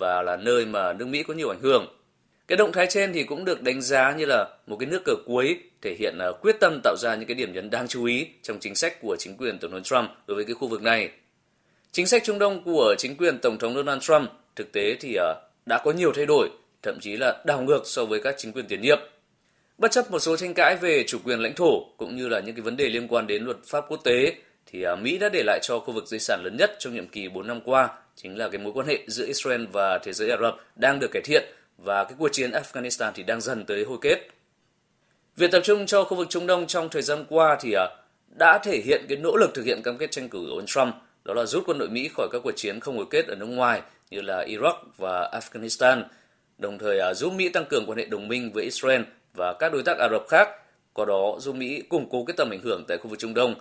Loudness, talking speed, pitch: -24 LUFS, 270 wpm, 175 Hz